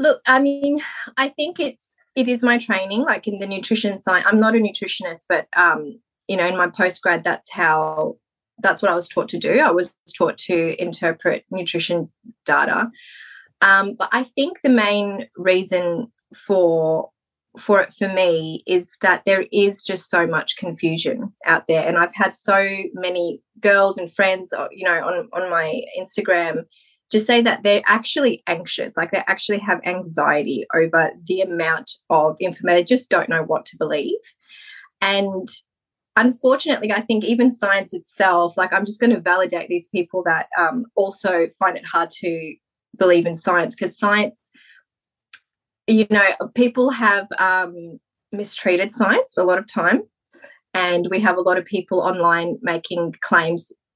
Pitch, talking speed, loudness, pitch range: 195 Hz, 165 wpm, -19 LUFS, 175-225 Hz